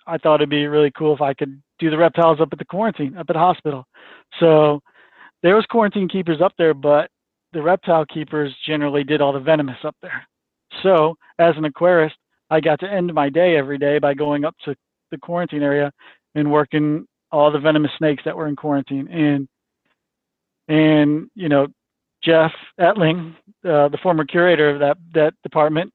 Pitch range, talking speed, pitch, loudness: 145-170 Hz, 185 wpm, 155 Hz, -18 LUFS